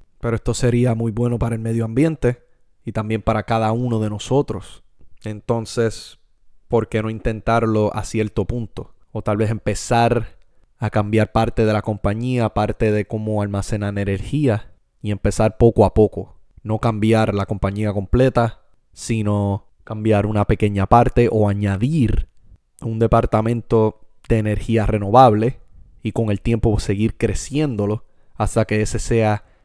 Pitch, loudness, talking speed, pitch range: 110 Hz, -19 LUFS, 145 wpm, 105-115 Hz